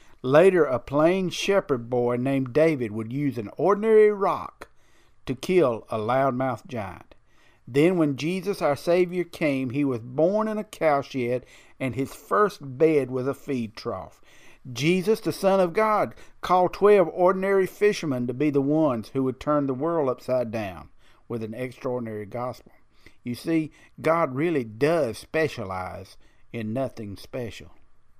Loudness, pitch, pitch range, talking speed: -24 LUFS, 140 Hz, 120-170 Hz, 150 wpm